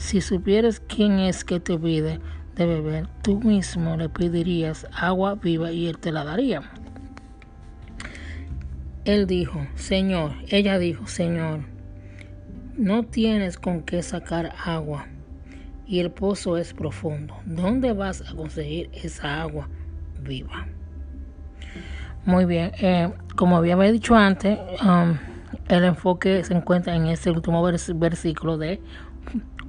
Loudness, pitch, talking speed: -23 LUFS, 170 Hz, 125 wpm